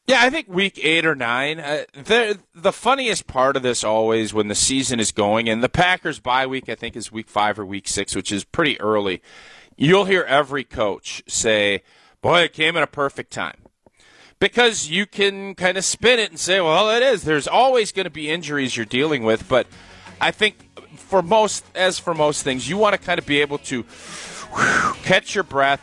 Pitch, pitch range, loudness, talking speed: 145 Hz, 115-190 Hz, -19 LUFS, 210 wpm